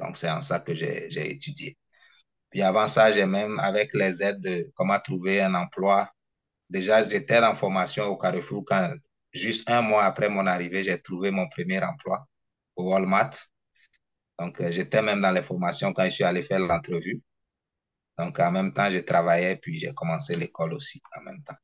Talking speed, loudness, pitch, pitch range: 190 wpm, -25 LUFS, 100 Hz, 95-110 Hz